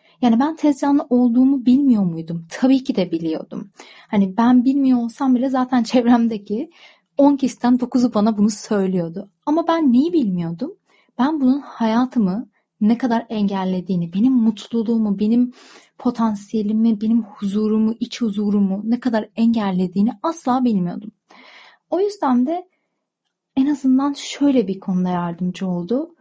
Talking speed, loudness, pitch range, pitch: 130 wpm, -19 LUFS, 205-260 Hz, 235 Hz